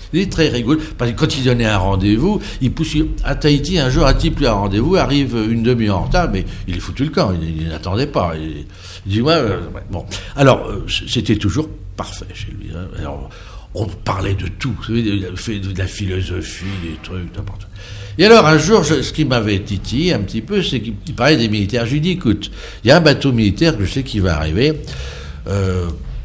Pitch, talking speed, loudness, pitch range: 105 Hz, 225 wpm, -16 LUFS, 95-140 Hz